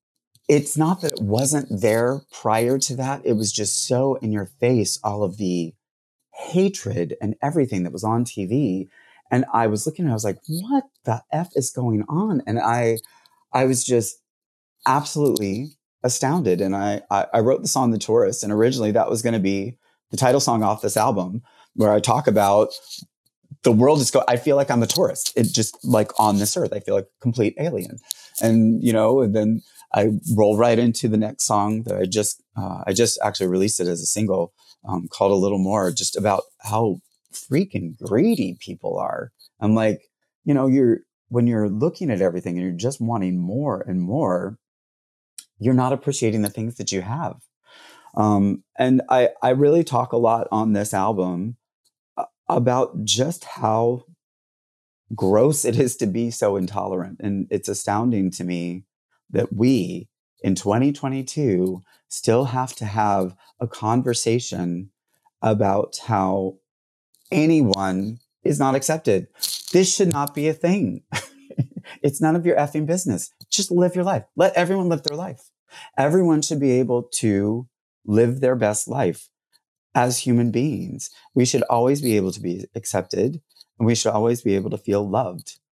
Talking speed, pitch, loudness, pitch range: 175 wpm, 115 Hz, -21 LUFS, 105-135 Hz